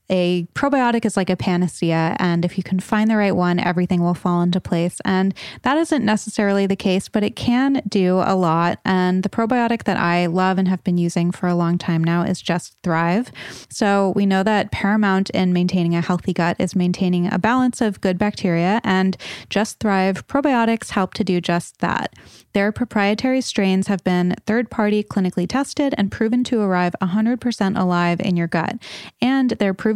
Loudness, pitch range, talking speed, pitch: -19 LUFS, 180-215 Hz, 190 wpm, 190 Hz